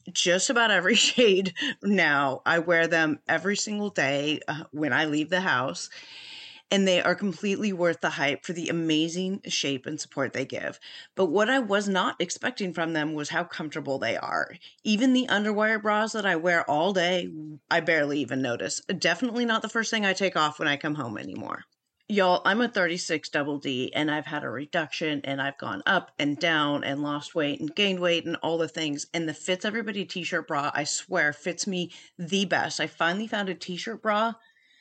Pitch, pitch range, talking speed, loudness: 170 Hz, 150-200 Hz, 200 wpm, -26 LUFS